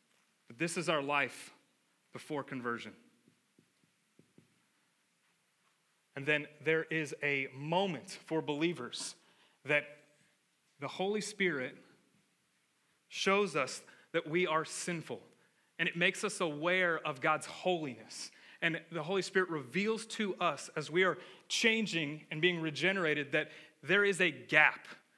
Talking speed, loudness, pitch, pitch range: 120 wpm, -34 LUFS, 160 Hz, 150-185 Hz